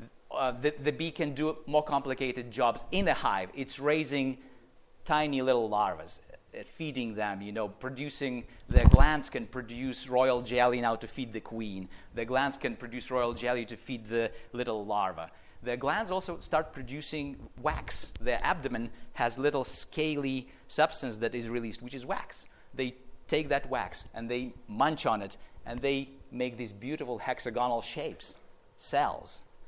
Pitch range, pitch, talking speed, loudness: 115-140 Hz, 125 Hz, 160 wpm, -32 LUFS